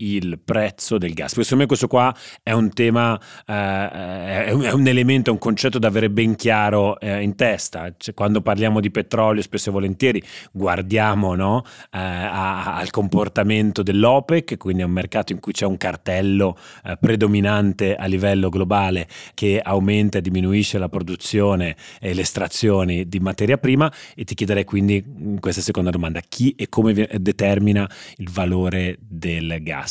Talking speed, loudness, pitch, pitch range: 165 wpm, -20 LUFS, 100 Hz, 95-110 Hz